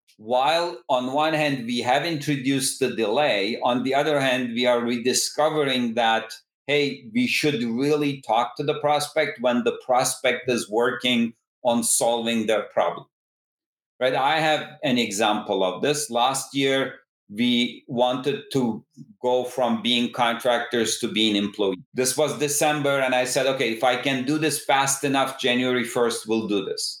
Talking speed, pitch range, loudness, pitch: 160 wpm, 120-150 Hz, -23 LUFS, 130 Hz